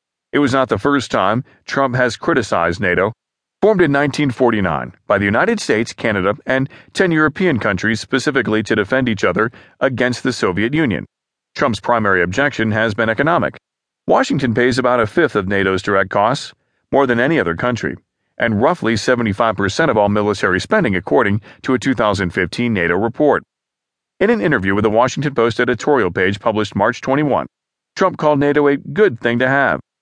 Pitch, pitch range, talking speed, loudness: 120 Hz, 105-135 Hz, 170 wpm, -16 LUFS